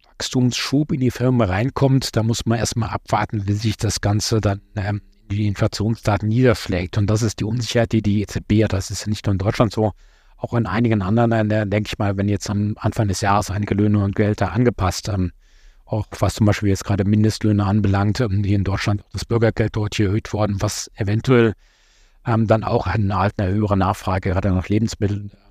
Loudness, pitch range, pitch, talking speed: -20 LUFS, 100-115 Hz, 105 Hz, 210 wpm